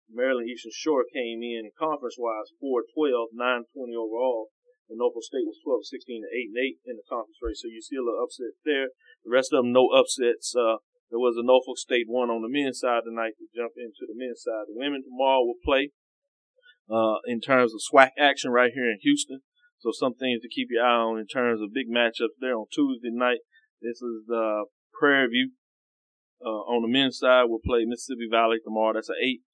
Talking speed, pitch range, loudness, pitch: 205 wpm, 115-150 Hz, -26 LUFS, 125 Hz